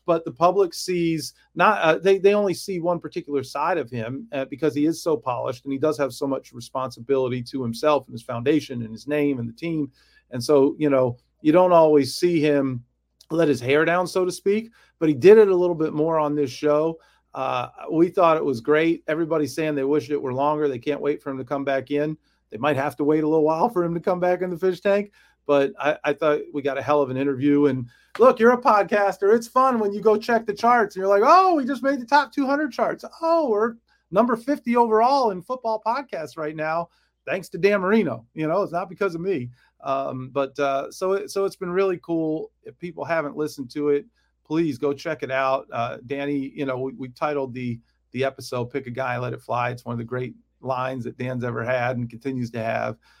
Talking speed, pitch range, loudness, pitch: 240 wpm, 135-190 Hz, -22 LUFS, 155 Hz